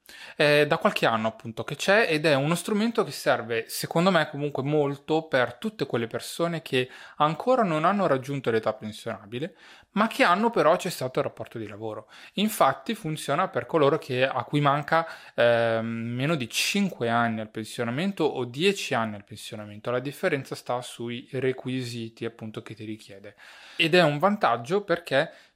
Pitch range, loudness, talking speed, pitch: 115-170 Hz, -25 LUFS, 165 wpm, 140 Hz